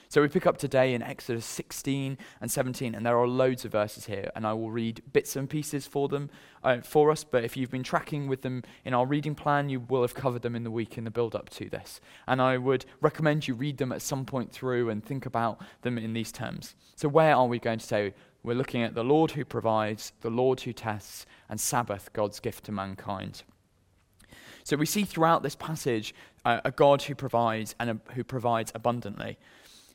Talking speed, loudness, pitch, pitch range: 230 wpm, -29 LUFS, 125 Hz, 115-140 Hz